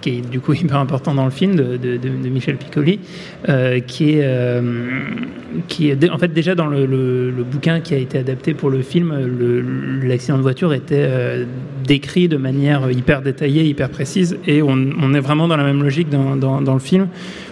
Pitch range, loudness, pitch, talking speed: 130-160 Hz, -17 LUFS, 140 Hz, 210 wpm